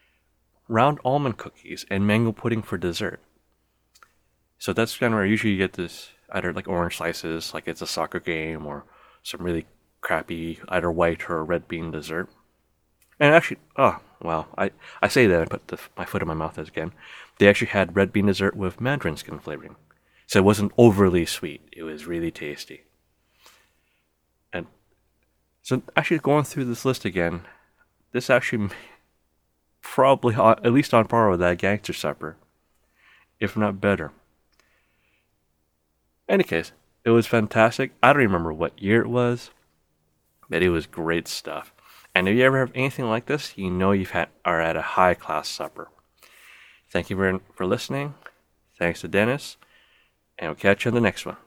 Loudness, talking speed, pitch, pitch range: -23 LUFS, 175 wpm, 95 Hz, 80-115 Hz